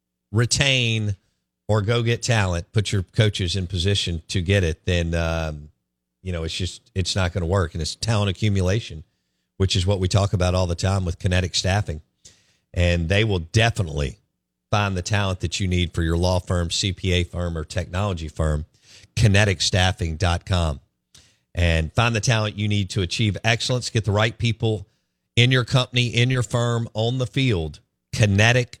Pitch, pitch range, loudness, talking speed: 95 Hz, 85-110 Hz, -22 LUFS, 175 wpm